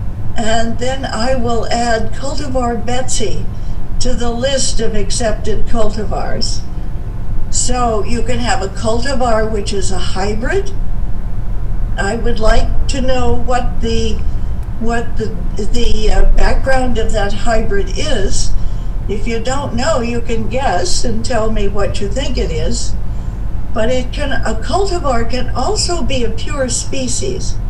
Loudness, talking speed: -18 LUFS, 140 wpm